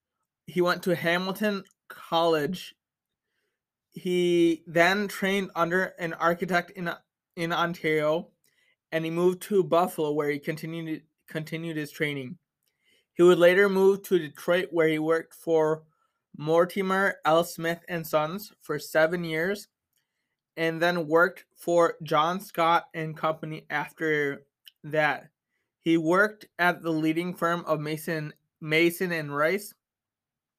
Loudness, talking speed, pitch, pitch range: -26 LUFS, 125 wpm, 170 Hz, 160-180 Hz